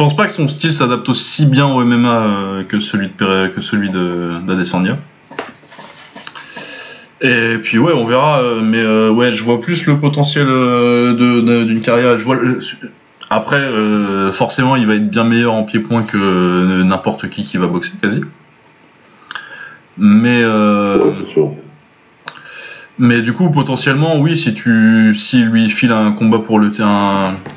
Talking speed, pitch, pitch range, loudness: 160 wpm, 115 Hz, 105-125 Hz, -13 LUFS